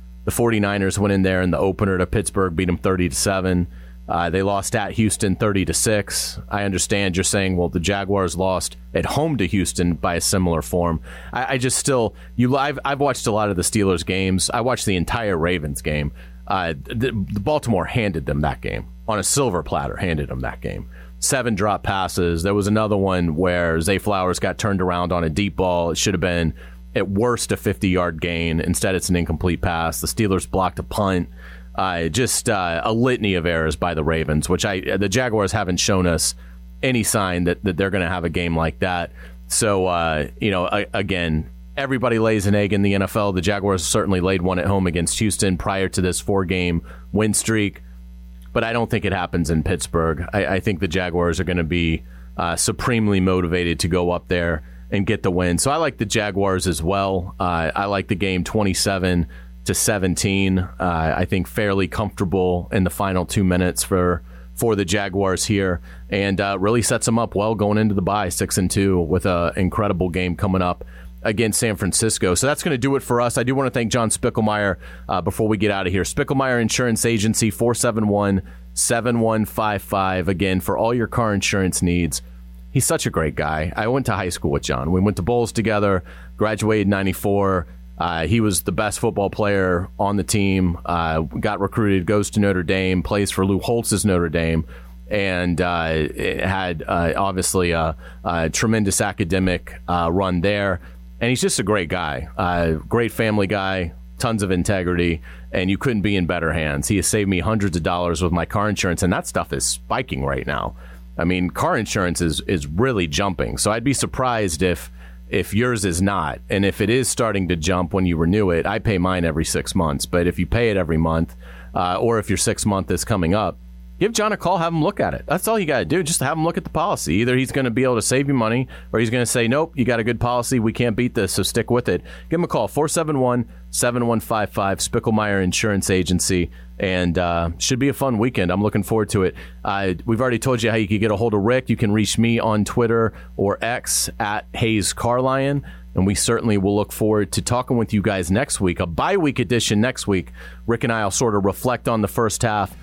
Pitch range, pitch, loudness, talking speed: 85-110 Hz, 95 Hz, -20 LUFS, 215 wpm